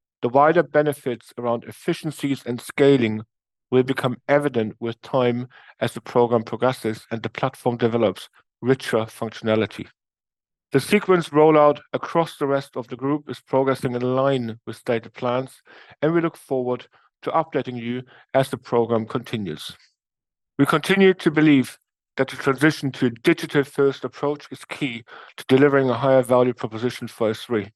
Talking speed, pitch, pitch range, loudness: 155 wpm, 130 Hz, 115-145 Hz, -22 LUFS